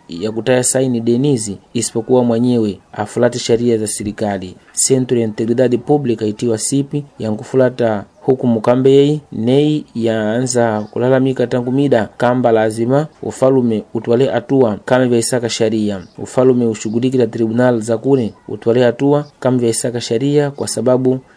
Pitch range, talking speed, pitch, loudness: 115-130 Hz, 120 wpm, 120 Hz, -15 LUFS